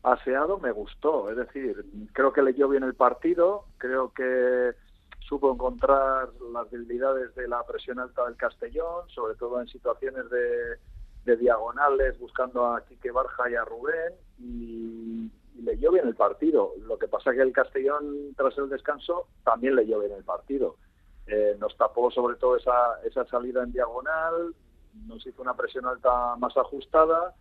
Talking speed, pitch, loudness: 170 wpm, 135 Hz, -27 LUFS